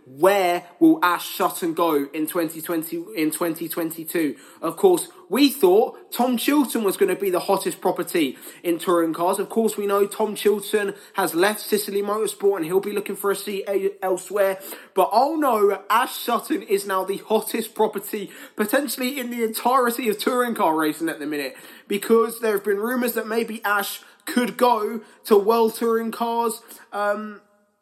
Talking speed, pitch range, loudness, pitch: 170 wpm, 190-235 Hz, -22 LUFS, 205 Hz